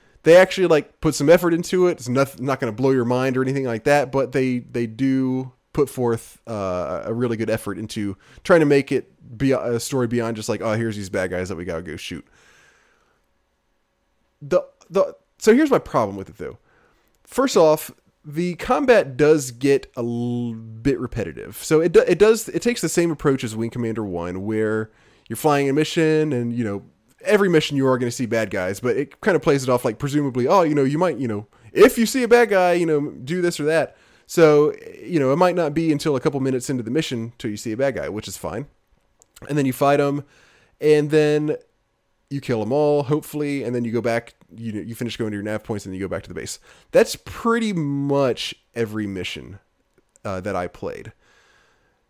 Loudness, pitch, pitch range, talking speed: -21 LUFS, 135 Hz, 115-155 Hz, 225 wpm